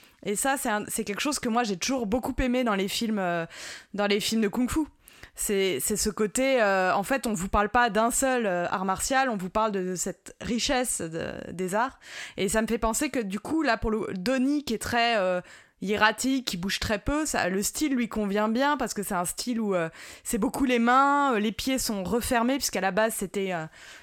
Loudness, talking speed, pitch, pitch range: -26 LUFS, 240 wpm, 225 Hz, 200-255 Hz